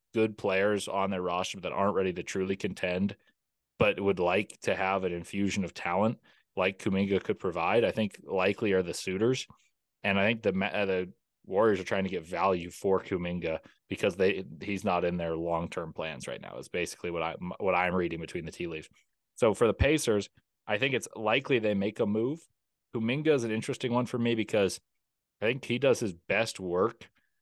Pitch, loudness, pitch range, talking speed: 100 Hz, -30 LUFS, 90-110 Hz, 200 wpm